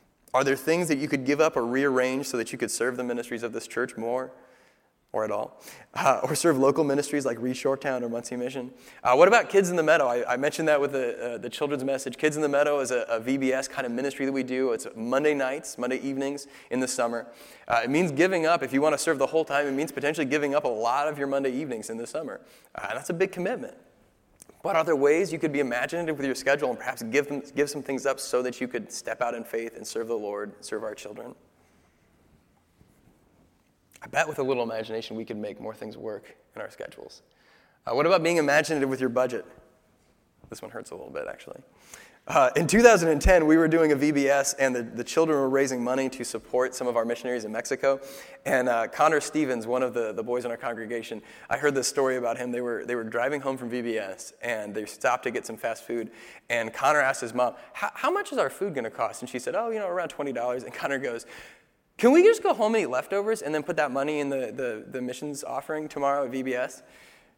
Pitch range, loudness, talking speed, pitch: 120-150 Hz, -26 LUFS, 240 wpm, 135 Hz